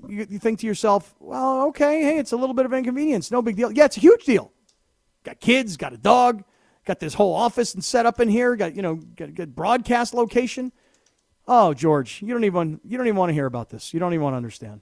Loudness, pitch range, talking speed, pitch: -21 LUFS, 180-245 Hz, 255 wpm, 230 Hz